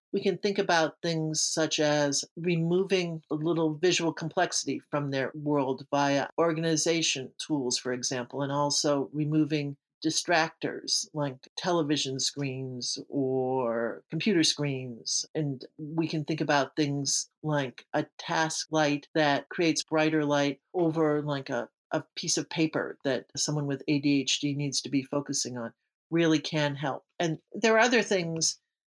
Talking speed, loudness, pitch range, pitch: 140 wpm, -28 LUFS, 140-160 Hz, 150 Hz